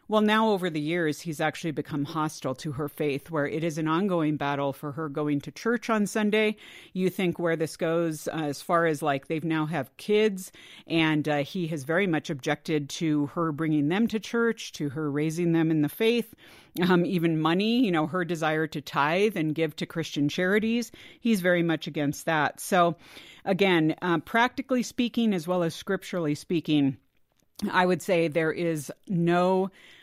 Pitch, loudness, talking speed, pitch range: 165 Hz, -27 LUFS, 190 wpm, 155-190 Hz